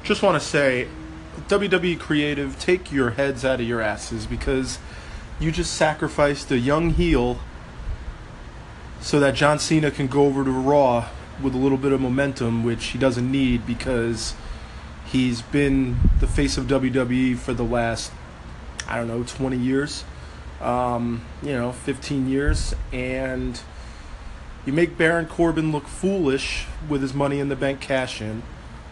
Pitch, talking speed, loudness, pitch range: 130 Hz, 155 wpm, -23 LUFS, 115-140 Hz